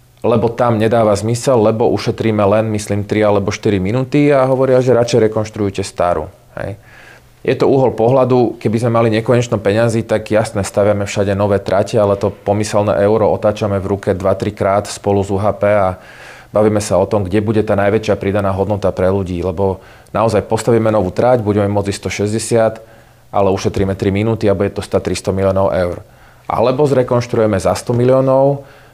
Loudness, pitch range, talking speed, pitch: -15 LUFS, 100-115 Hz, 170 wpm, 105 Hz